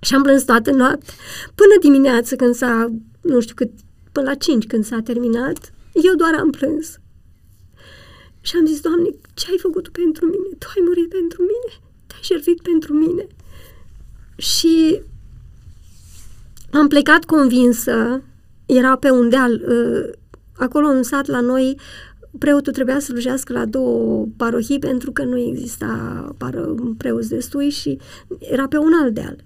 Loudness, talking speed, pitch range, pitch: -17 LUFS, 150 wpm, 235-320 Hz, 265 Hz